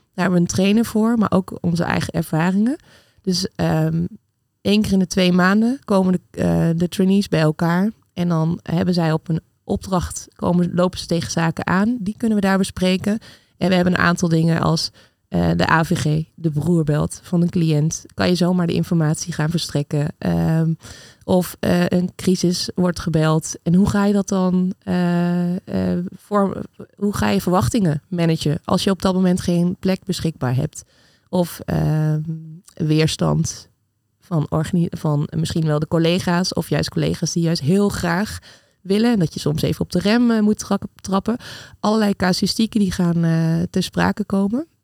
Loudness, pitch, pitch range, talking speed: -19 LUFS, 175 Hz, 160-190 Hz, 180 wpm